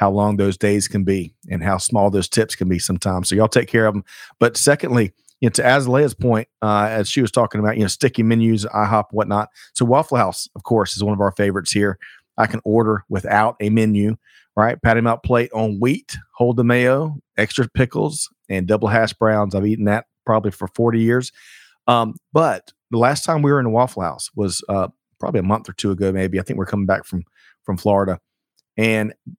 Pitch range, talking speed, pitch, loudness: 100-120 Hz, 220 wpm, 110 Hz, -19 LUFS